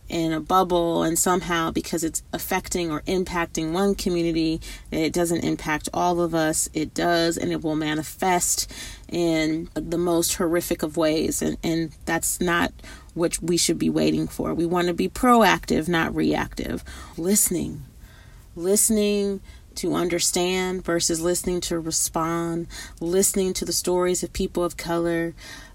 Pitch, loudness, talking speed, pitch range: 170 Hz, -23 LUFS, 145 wpm, 160-180 Hz